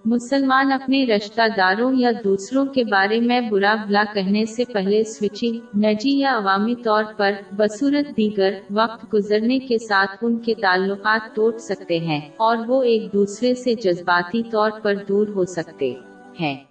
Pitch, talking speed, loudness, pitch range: 215 Hz, 160 wpm, -20 LUFS, 200-235 Hz